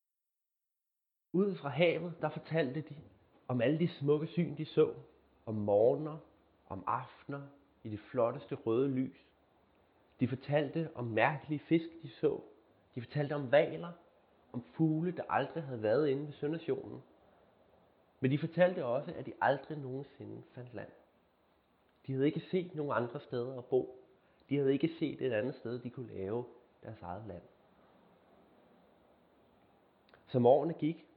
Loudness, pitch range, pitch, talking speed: -35 LUFS, 120-155 Hz, 140 Hz, 150 wpm